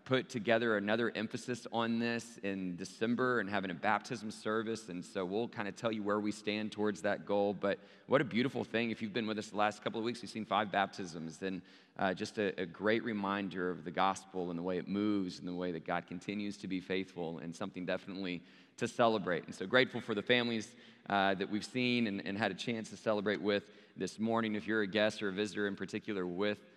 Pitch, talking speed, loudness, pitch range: 105 Hz, 235 wpm, -36 LUFS, 95-110 Hz